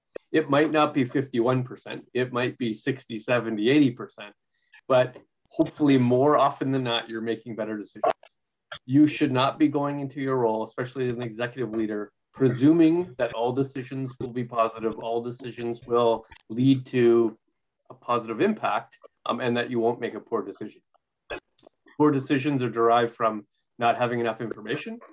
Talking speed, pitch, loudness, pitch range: 160 wpm, 120 Hz, -25 LUFS, 115-135 Hz